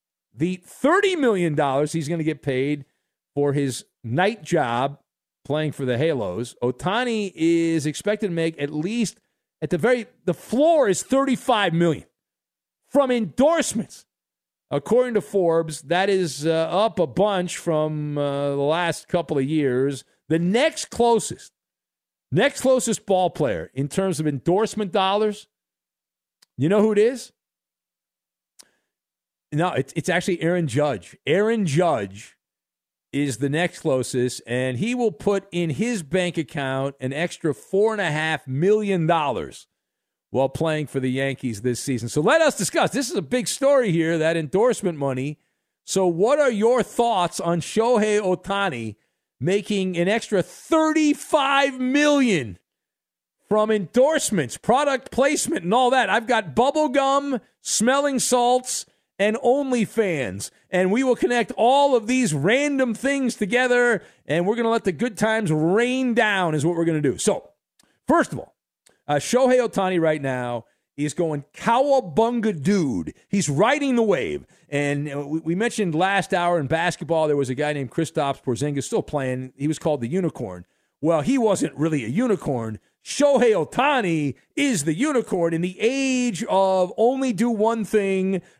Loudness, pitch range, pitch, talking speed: -22 LUFS, 150-235 Hz, 180 Hz, 155 wpm